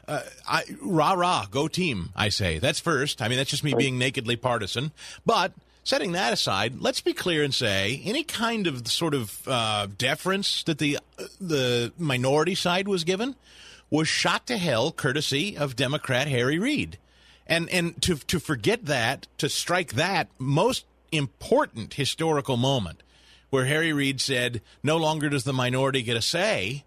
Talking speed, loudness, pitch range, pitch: 170 wpm, -25 LUFS, 125-160 Hz, 140 Hz